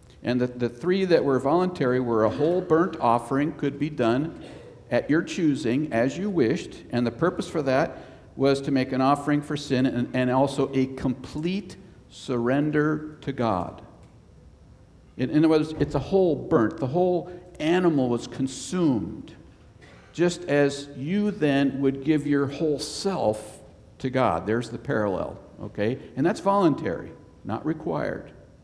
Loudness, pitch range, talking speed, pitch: -25 LUFS, 125-160 Hz, 155 wpm, 140 Hz